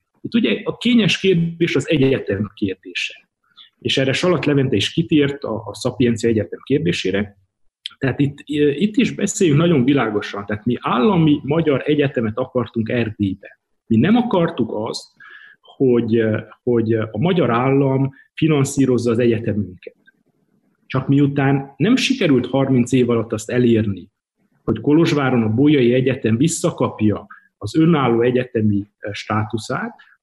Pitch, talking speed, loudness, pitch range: 130 Hz, 125 wpm, -18 LUFS, 115-155 Hz